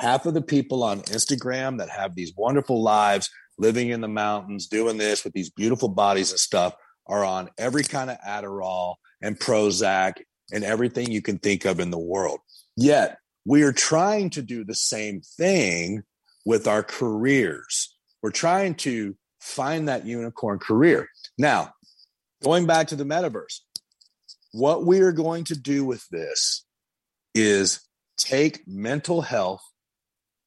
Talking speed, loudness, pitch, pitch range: 150 wpm, -23 LUFS, 115 Hz, 100-140 Hz